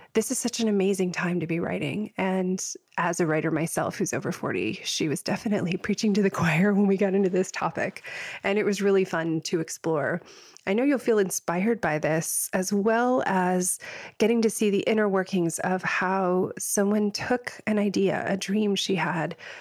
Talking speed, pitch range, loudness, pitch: 195 wpm, 180-210 Hz, -26 LUFS, 195 Hz